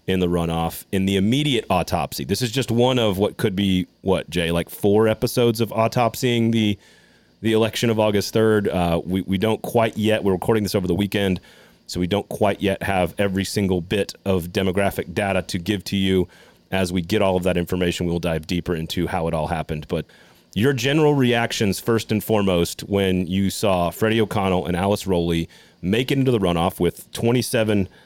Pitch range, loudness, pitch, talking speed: 90-110 Hz, -21 LUFS, 100 Hz, 200 wpm